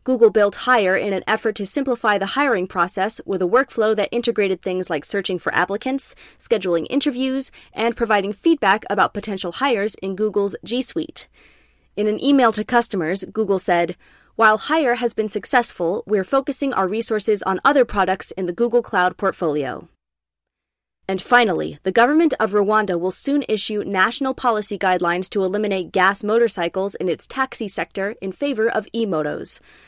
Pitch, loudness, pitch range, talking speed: 205 Hz, -20 LUFS, 190-235 Hz, 165 wpm